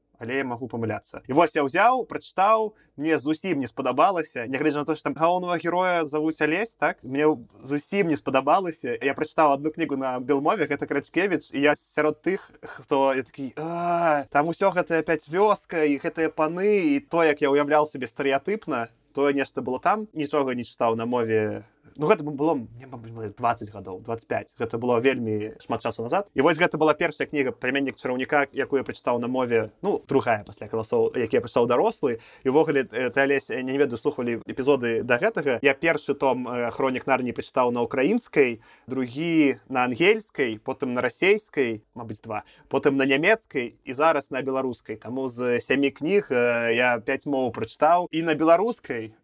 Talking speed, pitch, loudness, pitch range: 165 wpm, 140 Hz, -24 LUFS, 125-160 Hz